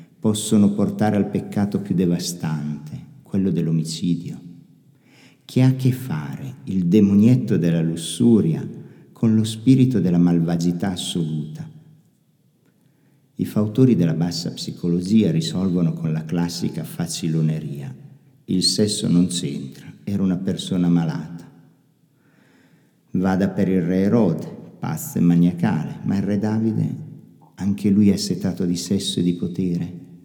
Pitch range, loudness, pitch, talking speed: 85-110 Hz, -20 LUFS, 95 Hz, 125 wpm